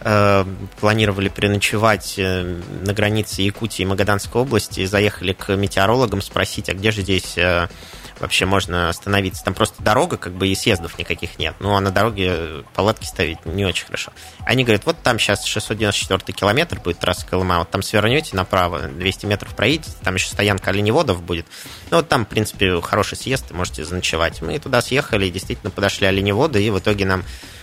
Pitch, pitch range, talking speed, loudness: 100 Hz, 90-105 Hz, 170 wpm, -19 LUFS